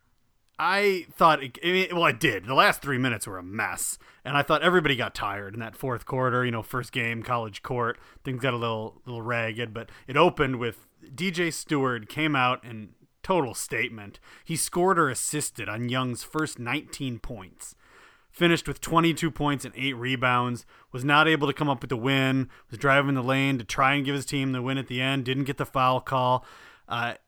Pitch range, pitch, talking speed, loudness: 120-145 Hz, 130 Hz, 205 wpm, -26 LUFS